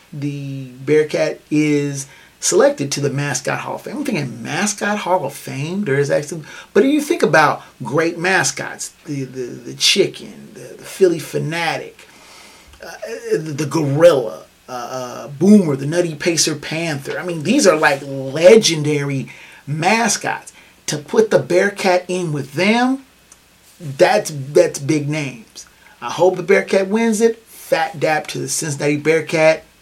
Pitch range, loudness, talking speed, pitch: 145-185 Hz, -17 LUFS, 150 wpm, 160 Hz